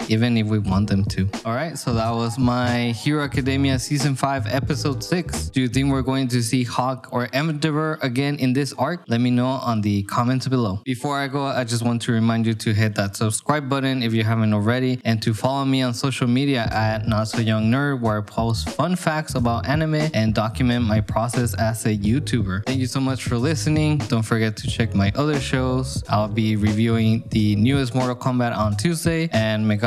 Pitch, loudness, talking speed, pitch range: 120 Hz, -21 LUFS, 210 wpm, 110-135 Hz